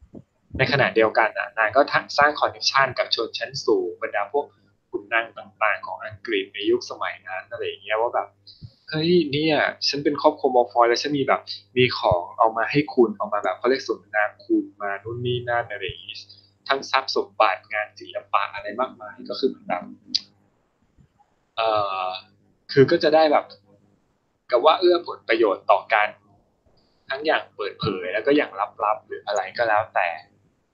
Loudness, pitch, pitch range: -22 LUFS, 145 Hz, 110-180 Hz